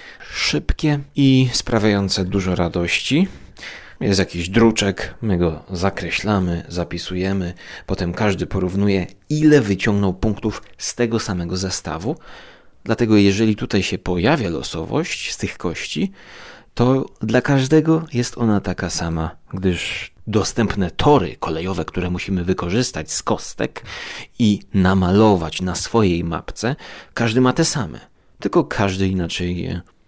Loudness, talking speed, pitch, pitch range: -20 LUFS, 120 wpm, 95 Hz, 90-115 Hz